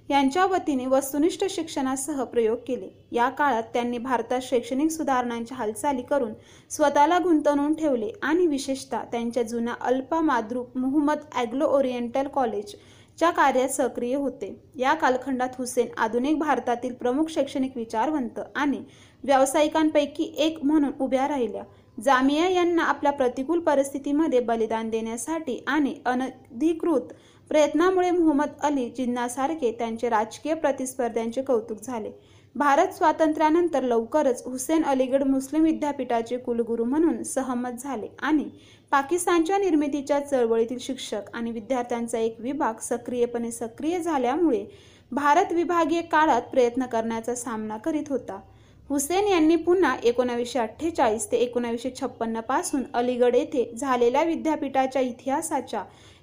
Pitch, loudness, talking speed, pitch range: 265 Hz, -25 LUFS, 105 wpm, 240-300 Hz